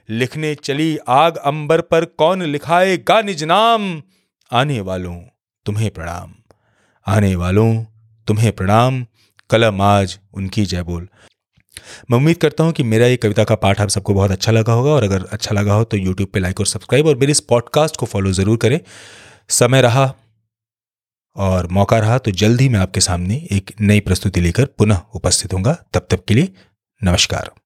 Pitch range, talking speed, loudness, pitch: 100-130 Hz, 175 wpm, -16 LUFS, 110 Hz